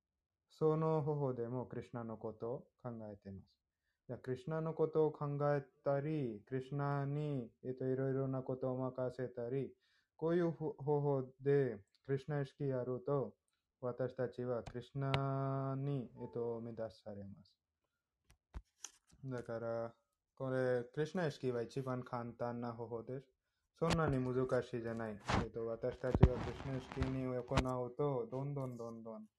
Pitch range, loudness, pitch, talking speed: 115-140 Hz, -40 LUFS, 130 Hz, 290 characters per minute